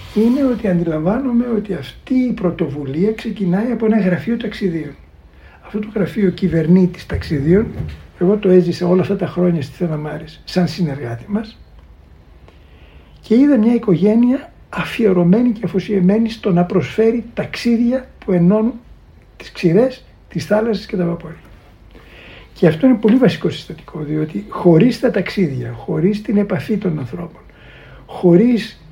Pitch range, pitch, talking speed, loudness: 165-220 Hz, 185 Hz, 135 wpm, -16 LUFS